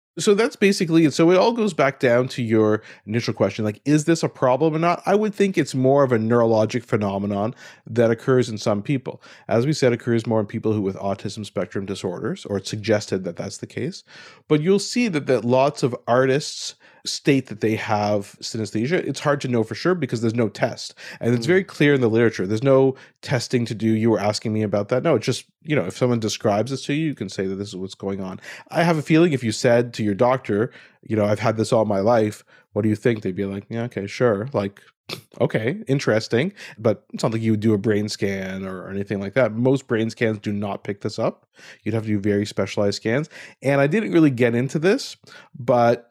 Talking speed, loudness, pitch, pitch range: 240 wpm, -21 LUFS, 115 Hz, 105-140 Hz